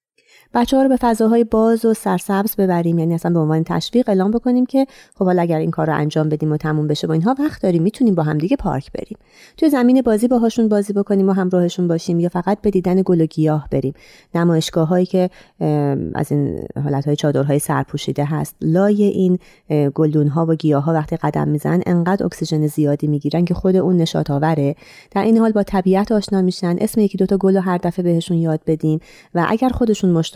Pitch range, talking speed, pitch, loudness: 155-205 Hz, 210 wpm, 175 Hz, -17 LUFS